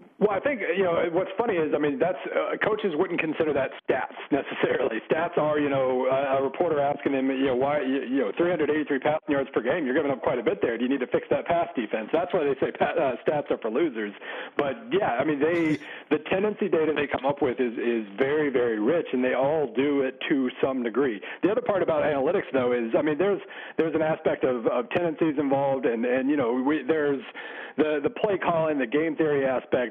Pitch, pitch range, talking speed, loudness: 150 Hz, 135-170 Hz, 235 wpm, -26 LUFS